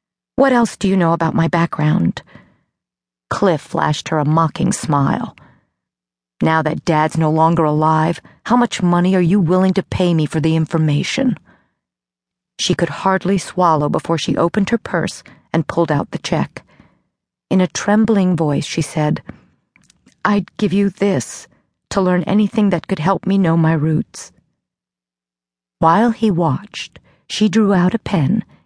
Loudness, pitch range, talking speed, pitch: -16 LUFS, 155-195 Hz, 155 wpm, 170 Hz